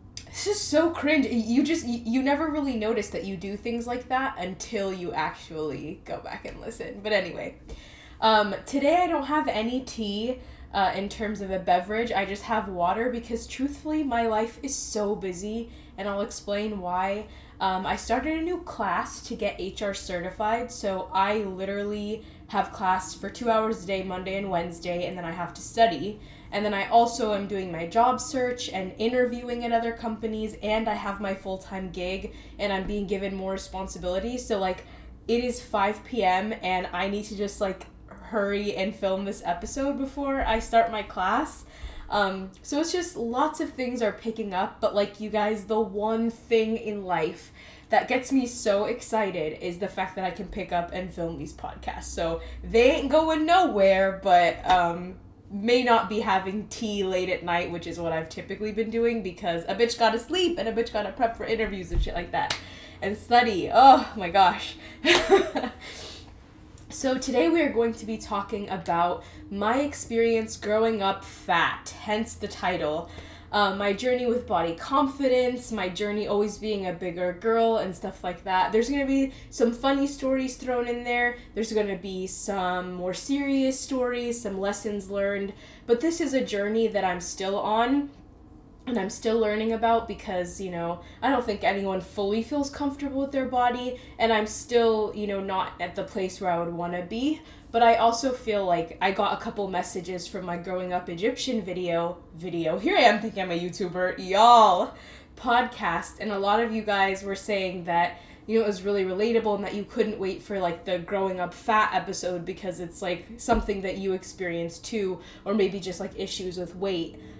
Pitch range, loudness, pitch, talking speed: 190-235 Hz, -26 LUFS, 210 Hz, 190 wpm